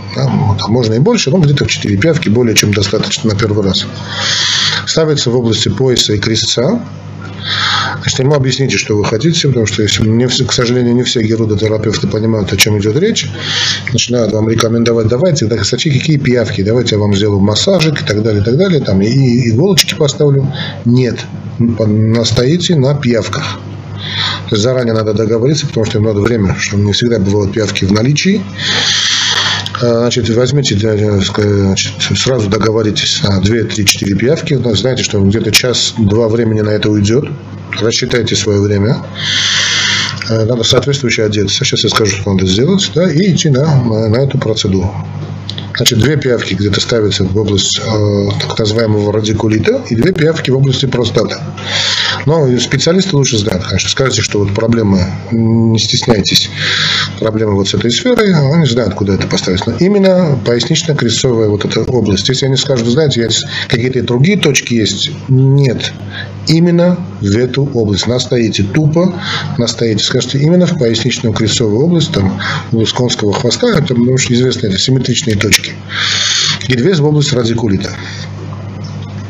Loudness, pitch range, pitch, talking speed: -11 LUFS, 105-130 Hz, 115 Hz, 150 wpm